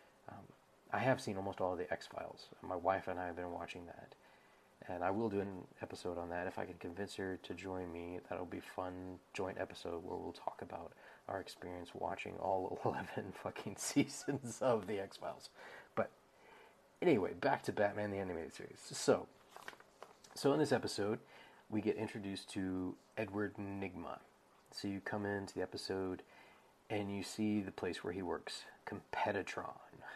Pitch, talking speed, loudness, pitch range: 95 Hz, 175 wpm, -41 LUFS, 90-100 Hz